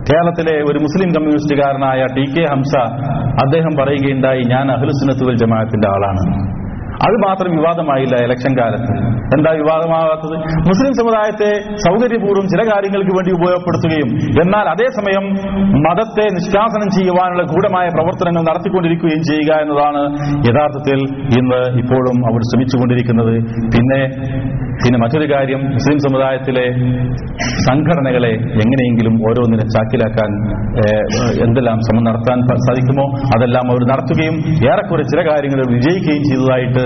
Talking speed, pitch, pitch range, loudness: 105 wpm, 135 Hz, 125-165 Hz, -14 LUFS